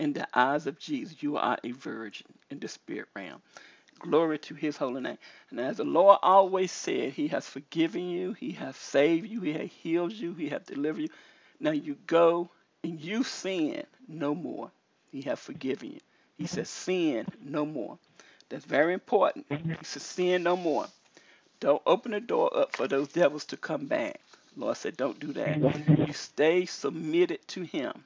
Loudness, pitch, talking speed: -29 LUFS, 180 Hz, 185 wpm